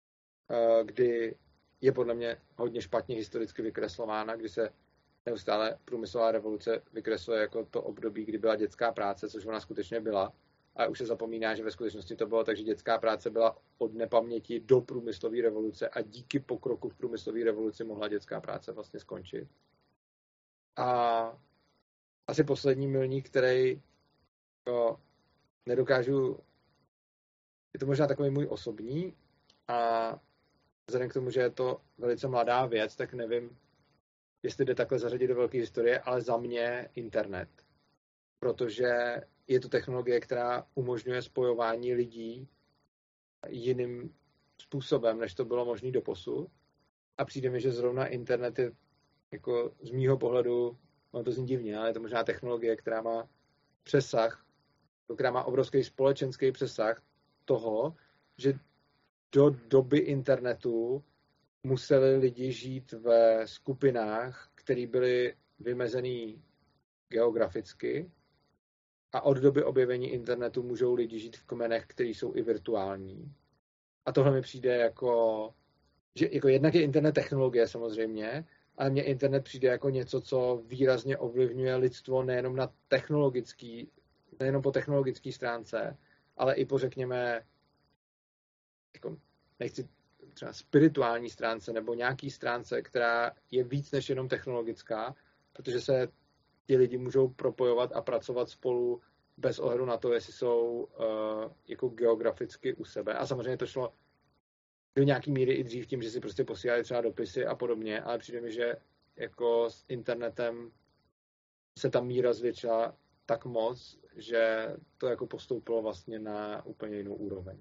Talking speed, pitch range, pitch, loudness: 135 wpm, 115-135 Hz, 125 Hz, -31 LUFS